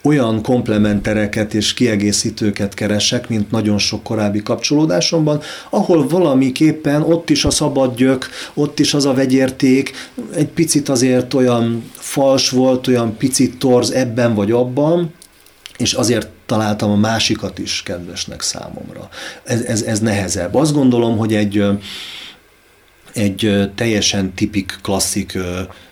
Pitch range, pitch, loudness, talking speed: 105-135 Hz, 120 Hz, -16 LUFS, 125 wpm